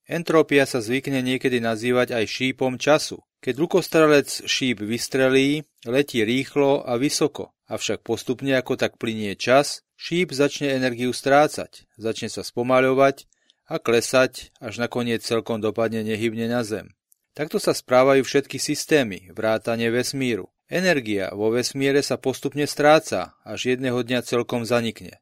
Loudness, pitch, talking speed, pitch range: -22 LUFS, 130 Hz, 135 wpm, 115-140 Hz